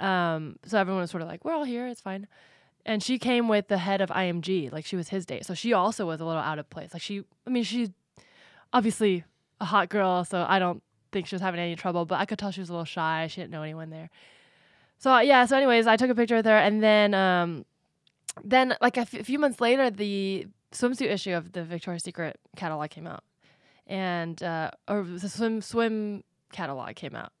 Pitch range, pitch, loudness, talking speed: 175-225 Hz, 195 Hz, -27 LUFS, 235 wpm